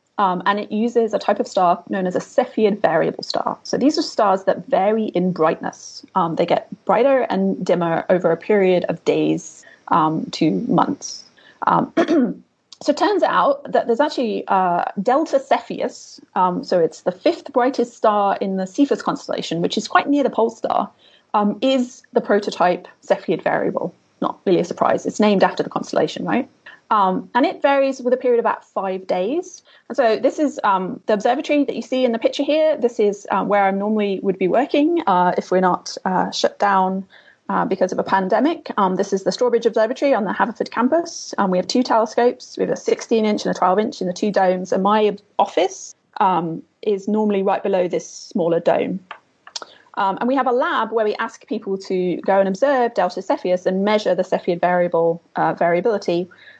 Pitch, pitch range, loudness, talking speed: 215 Hz, 190-260 Hz, -19 LUFS, 195 wpm